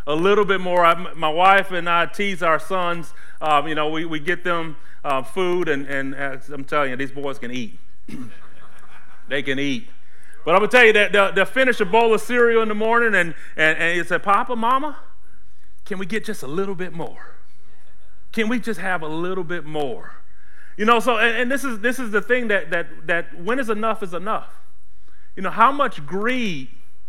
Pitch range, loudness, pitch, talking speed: 155-220 Hz, -20 LUFS, 180 Hz, 215 wpm